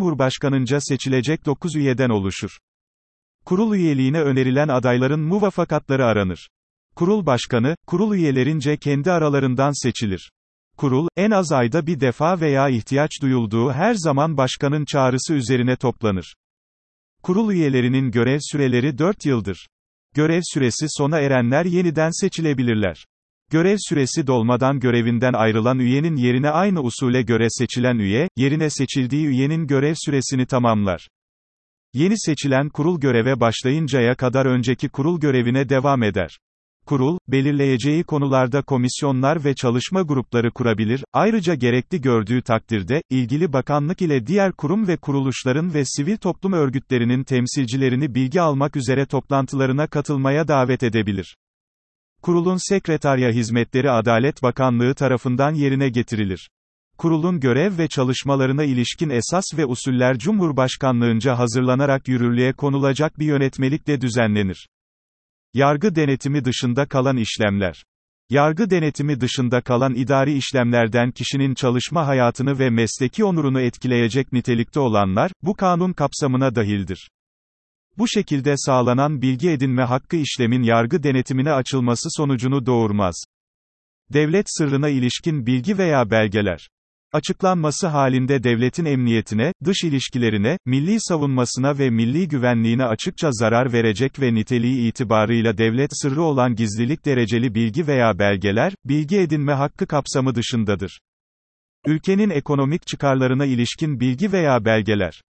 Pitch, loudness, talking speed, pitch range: 135 Hz, -19 LUFS, 120 wpm, 120-150 Hz